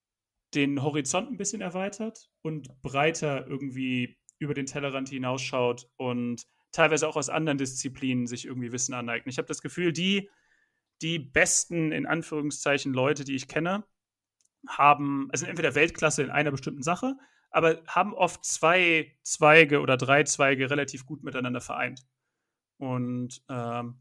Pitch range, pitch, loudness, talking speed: 130-160 Hz, 145 Hz, -27 LUFS, 145 wpm